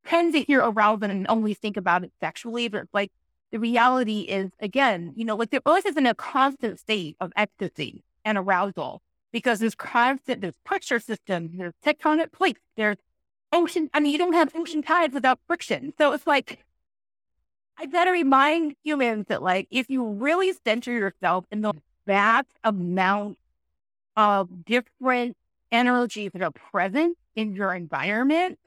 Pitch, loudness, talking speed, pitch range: 230 Hz, -24 LUFS, 160 wpm, 200-290 Hz